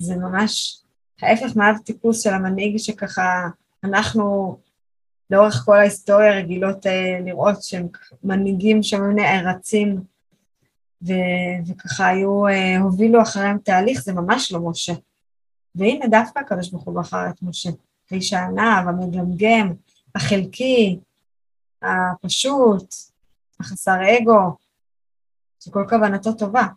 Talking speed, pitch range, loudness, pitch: 105 wpm, 180-210 Hz, -19 LUFS, 195 Hz